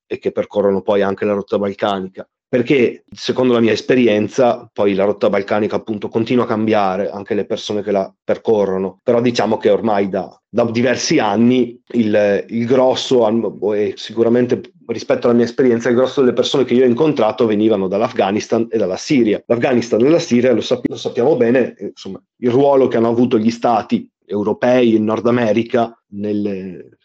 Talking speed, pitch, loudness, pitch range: 175 wpm, 115 Hz, -16 LUFS, 105-125 Hz